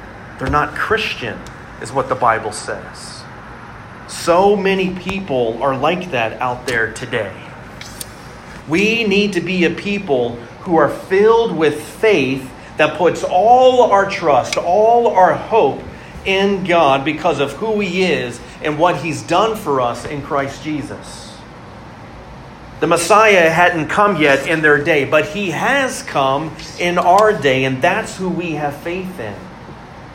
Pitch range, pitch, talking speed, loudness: 140-195 Hz, 170 Hz, 145 wpm, -15 LUFS